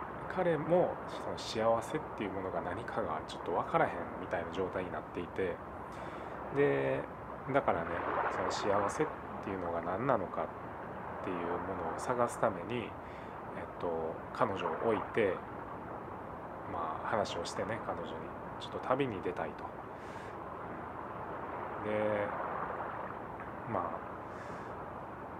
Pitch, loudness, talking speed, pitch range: 105 Hz, -37 LUFS, 235 characters per minute, 85-145 Hz